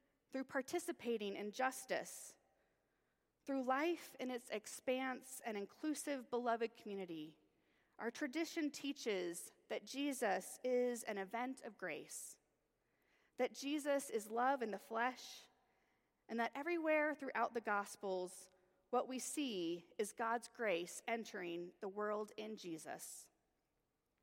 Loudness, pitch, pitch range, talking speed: -43 LUFS, 235 Hz, 205-265 Hz, 115 wpm